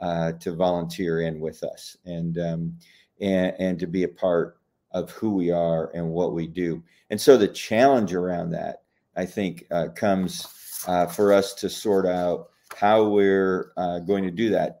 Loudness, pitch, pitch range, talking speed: -24 LUFS, 90 Hz, 85-95 Hz, 180 wpm